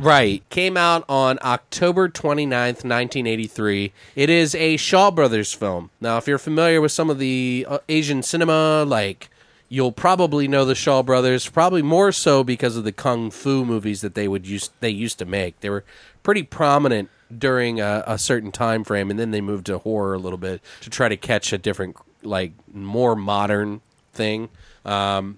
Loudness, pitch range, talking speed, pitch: -20 LUFS, 105-145 Hz, 180 wpm, 120 Hz